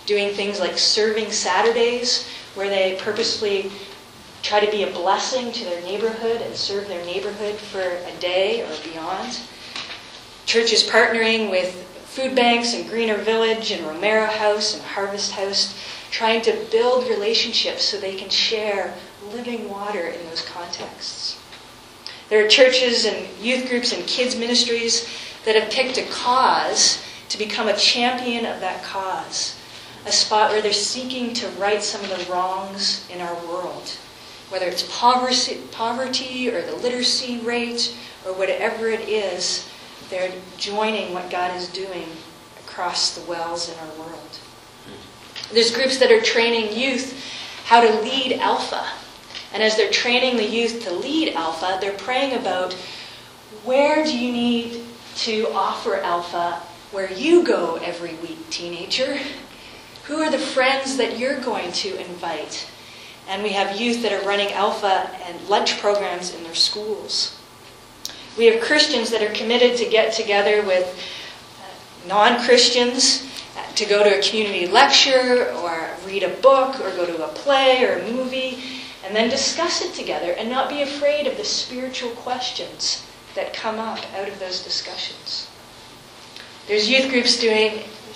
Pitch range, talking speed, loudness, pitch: 190-250 Hz, 150 wpm, -20 LUFS, 220 Hz